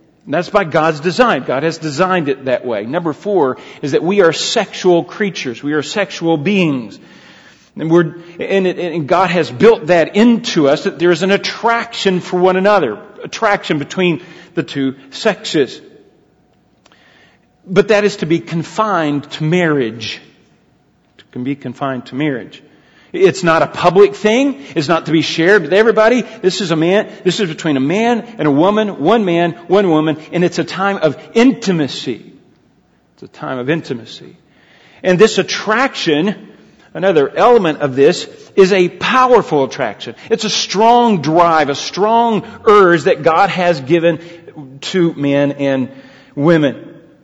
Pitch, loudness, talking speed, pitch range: 175 Hz, -14 LUFS, 160 wpm, 155-205 Hz